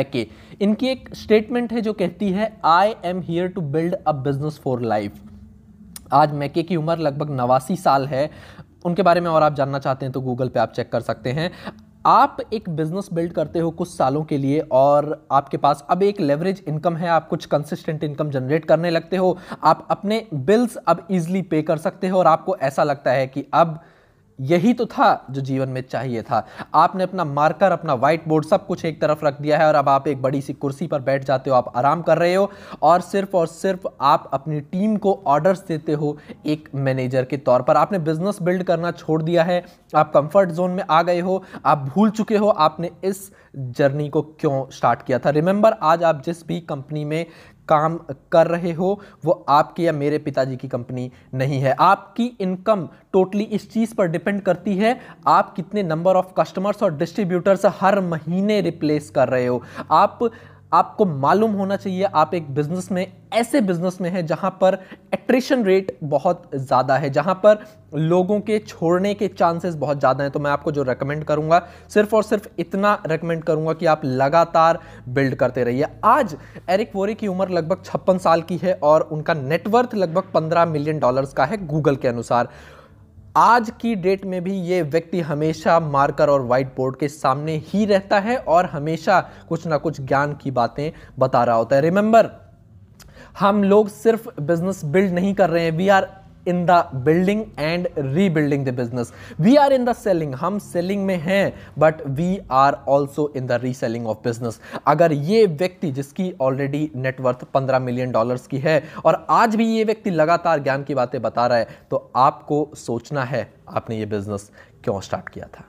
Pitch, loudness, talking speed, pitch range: 165 Hz, -20 LUFS, 195 wpm, 140-190 Hz